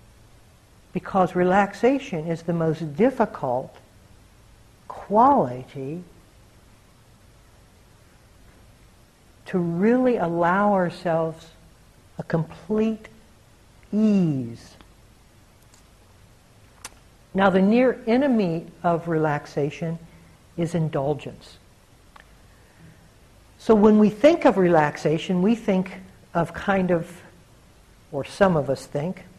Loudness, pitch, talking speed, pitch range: -22 LUFS, 160 Hz, 80 wpm, 115-190 Hz